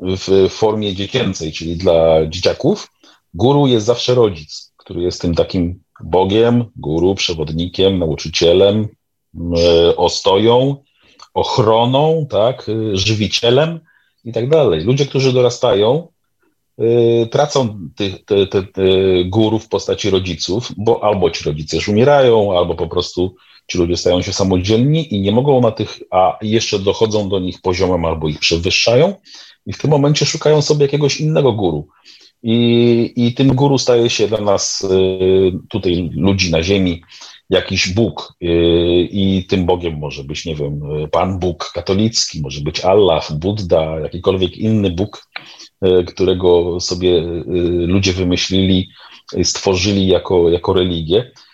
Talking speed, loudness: 130 wpm, -15 LUFS